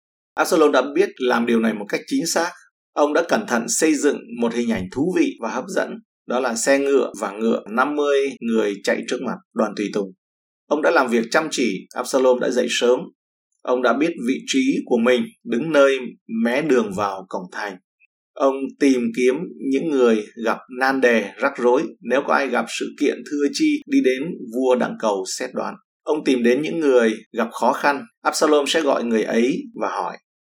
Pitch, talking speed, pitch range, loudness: 130 Hz, 200 wpm, 115-145 Hz, -20 LUFS